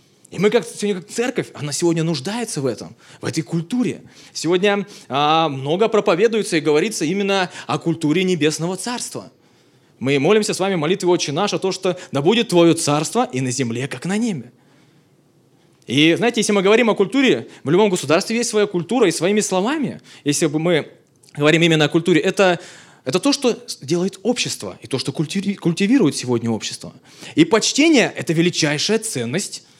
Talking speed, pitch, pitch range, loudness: 170 wpm, 175 Hz, 150-205 Hz, -18 LUFS